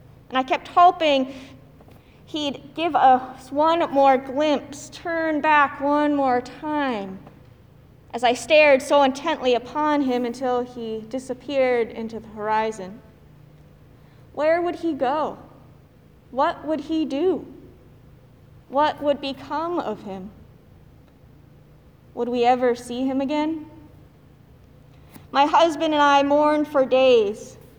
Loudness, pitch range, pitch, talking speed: -21 LUFS, 240-300 Hz, 275 Hz, 115 wpm